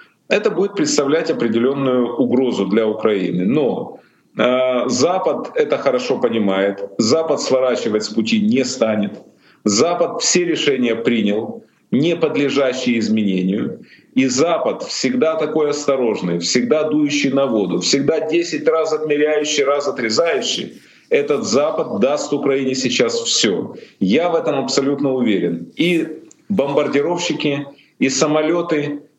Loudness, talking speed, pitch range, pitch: -17 LUFS, 115 wpm, 125-165 Hz, 145 Hz